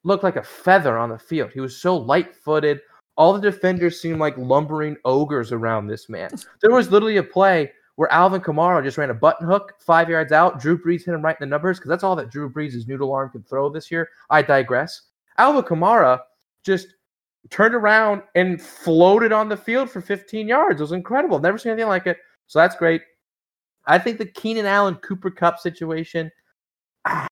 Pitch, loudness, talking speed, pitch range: 170 Hz, -19 LUFS, 200 wpm, 150-195 Hz